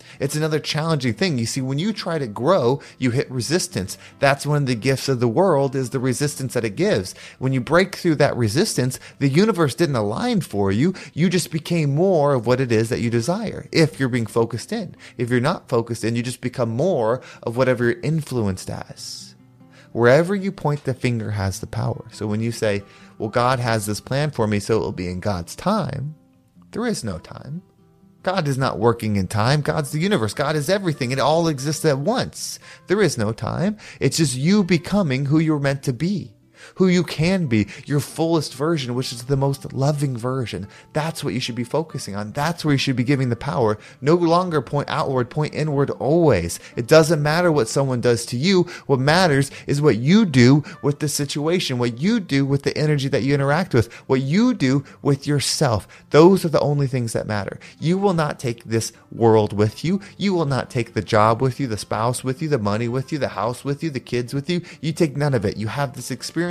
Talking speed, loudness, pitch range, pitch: 220 wpm, -21 LUFS, 120-160 Hz, 140 Hz